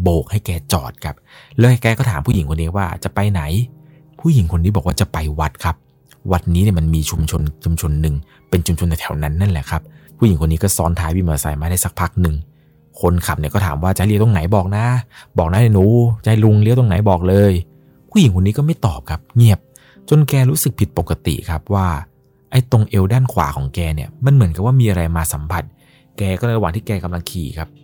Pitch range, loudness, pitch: 80-110 Hz, -17 LUFS, 95 Hz